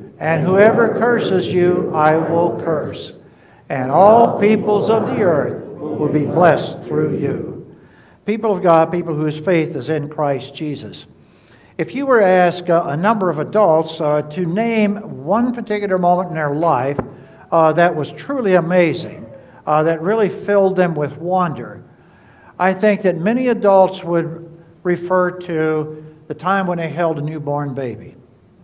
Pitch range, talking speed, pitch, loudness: 155-190 Hz, 155 wpm, 170 Hz, -16 LUFS